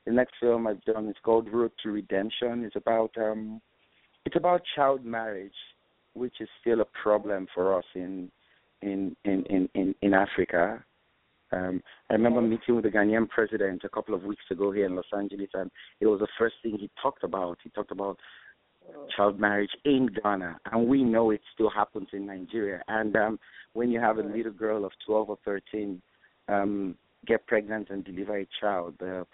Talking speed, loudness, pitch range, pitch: 190 wpm, -29 LUFS, 100-115 Hz, 105 Hz